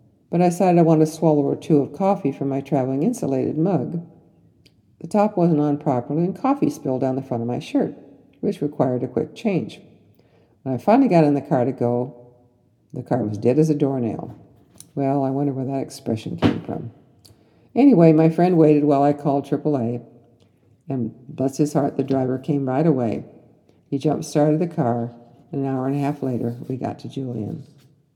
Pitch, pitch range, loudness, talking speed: 140 Hz, 125-155 Hz, -21 LUFS, 195 wpm